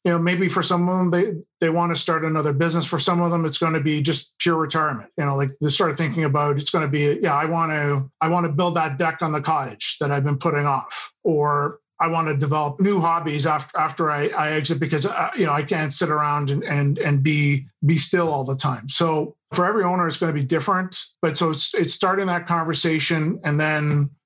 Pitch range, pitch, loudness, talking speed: 150-170 Hz, 160 Hz, -21 LUFS, 250 wpm